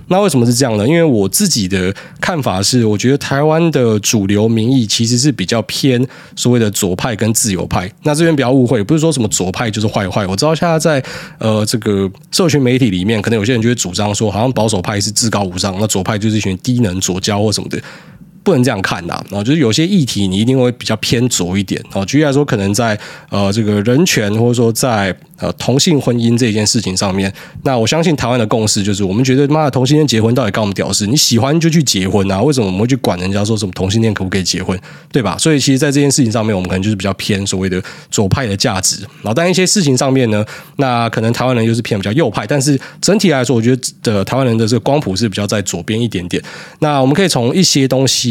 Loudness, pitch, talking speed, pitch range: -13 LUFS, 115 Hz, 385 characters per minute, 105-140 Hz